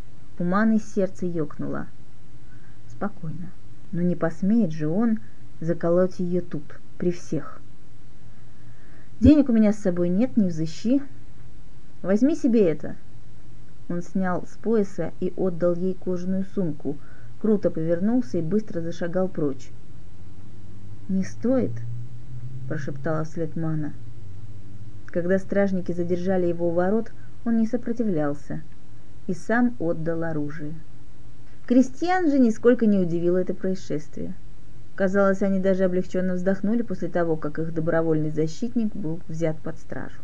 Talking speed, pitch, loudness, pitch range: 120 wpm, 175 Hz, -25 LUFS, 150-195 Hz